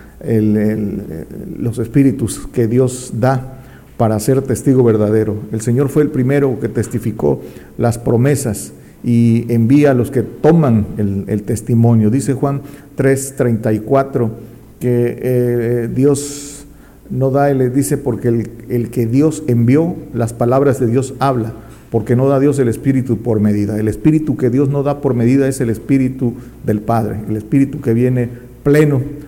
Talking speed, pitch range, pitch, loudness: 155 wpm, 115-135 Hz, 125 Hz, -15 LUFS